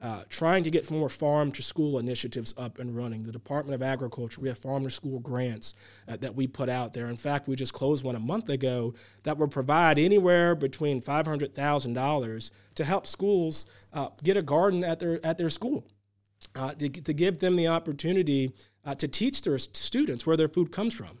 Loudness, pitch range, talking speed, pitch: -28 LUFS, 125-160 Hz, 190 wpm, 140 Hz